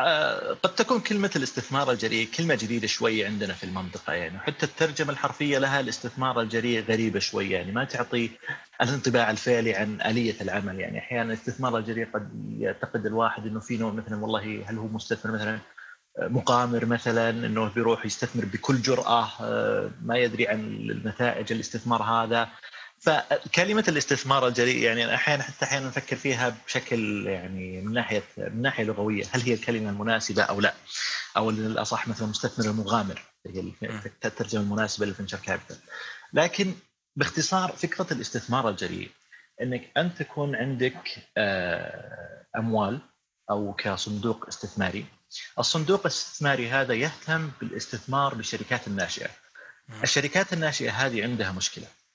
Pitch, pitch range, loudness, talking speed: 115 Hz, 110-135 Hz, -27 LUFS, 130 wpm